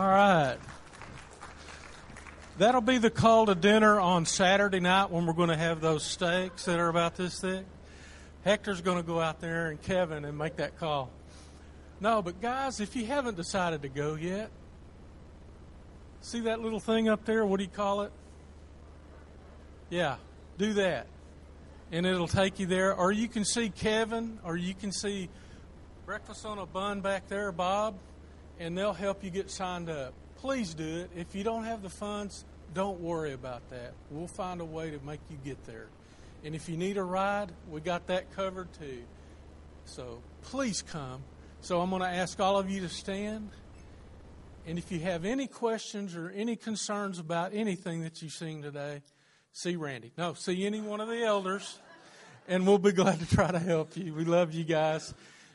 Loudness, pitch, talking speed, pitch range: -31 LUFS, 175 Hz, 185 wpm, 145-200 Hz